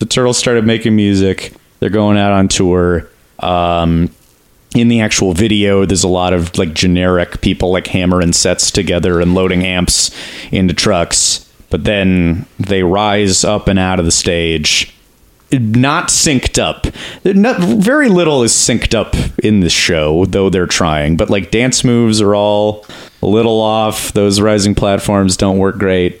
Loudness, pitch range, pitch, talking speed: -12 LUFS, 90-110 Hz, 95 Hz, 165 wpm